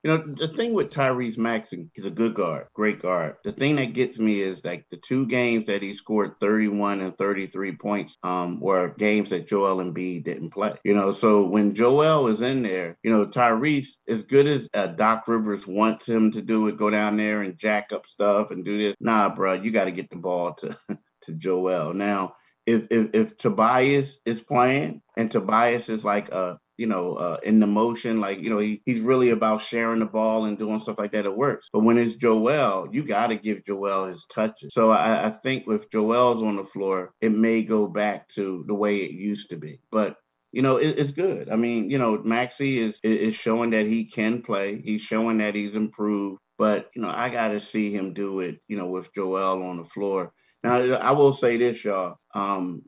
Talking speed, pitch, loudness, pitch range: 220 wpm, 110 Hz, -24 LUFS, 100-115 Hz